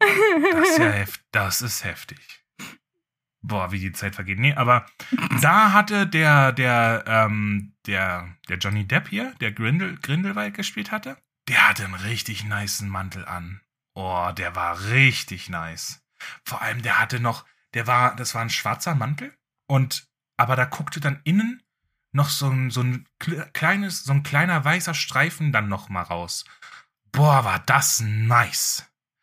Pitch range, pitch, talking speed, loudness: 105-155 Hz, 130 Hz, 160 wpm, -22 LUFS